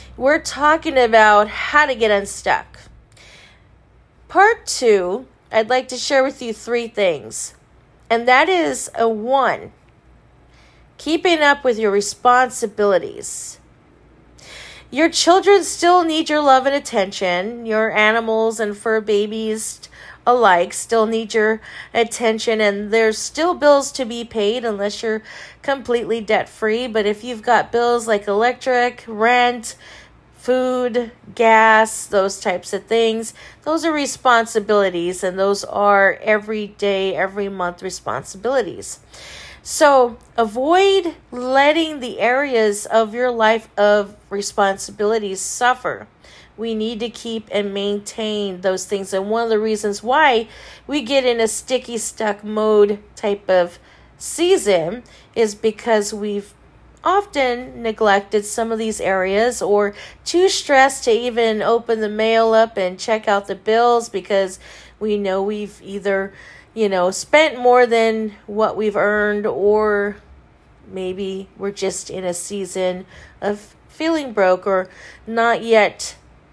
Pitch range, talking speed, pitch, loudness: 205-245 Hz, 130 wpm, 220 Hz, -18 LUFS